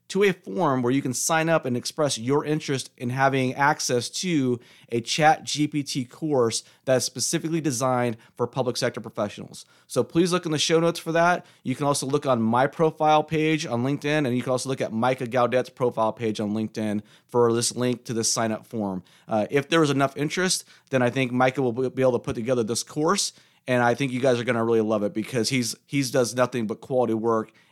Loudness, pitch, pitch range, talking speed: -24 LUFS, 130 Hz, 120-150 Hz, 220 wpm